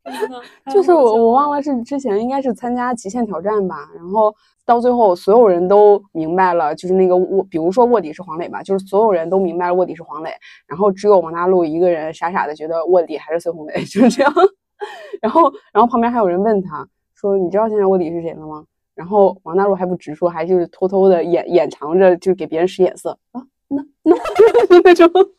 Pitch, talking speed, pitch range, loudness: 195 Hz, 330 characters per minute, 175-240 Hz, -15 LUFS